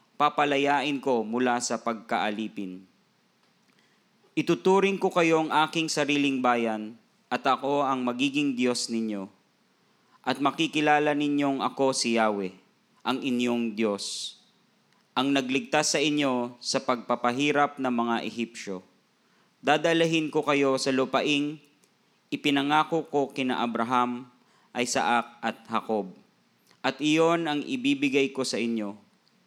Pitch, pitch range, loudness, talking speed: 135 Hz, 115-145 Hz, -26 LUFS, 110 wpm